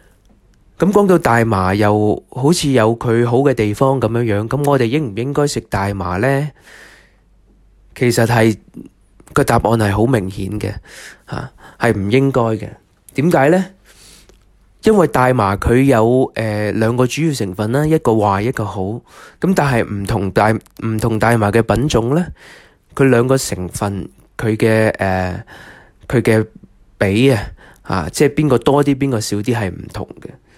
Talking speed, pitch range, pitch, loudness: 215 characters per minute, 105-135 Hz, 115 Hz, -15 LUFS